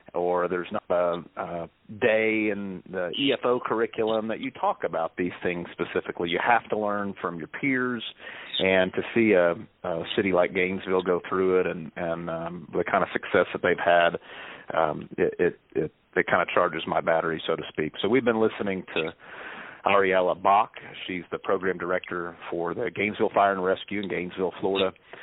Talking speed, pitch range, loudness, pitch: 185 wpm, 90-105 Hz, -26 LUFS, 95 Hz